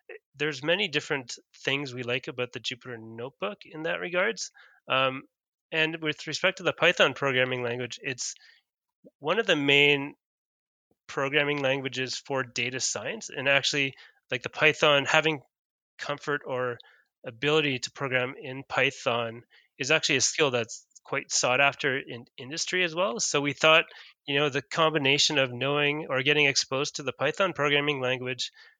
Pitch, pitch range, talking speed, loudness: 140 Hz, 130-155 Hz, 155 wpm, -26 LUFS